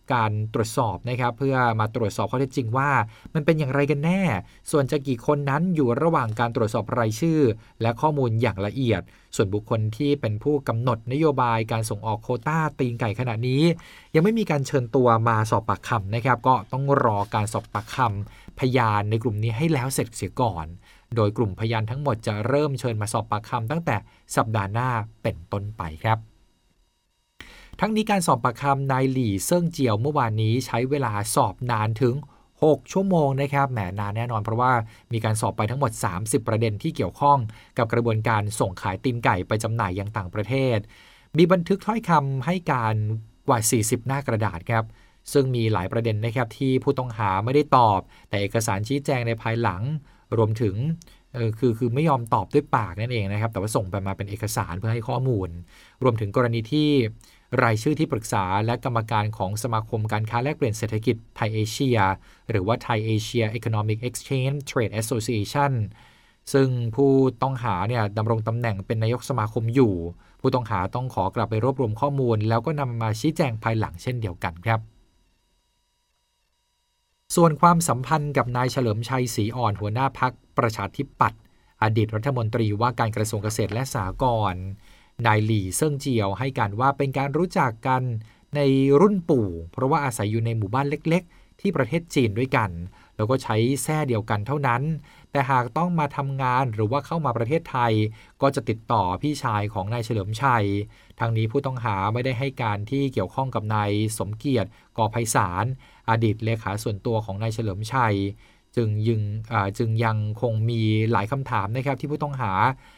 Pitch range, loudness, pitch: 110-135 Hz, -24 LUFS, 115 Hz